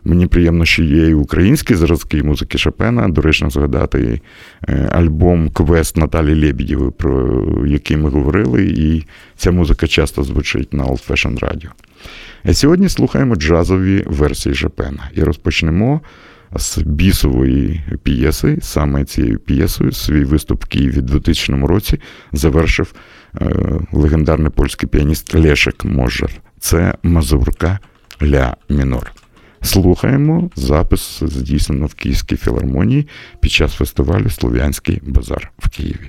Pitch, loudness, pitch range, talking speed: 80 Hz, -15 LUFS, 75-90 Hz, 120 wpm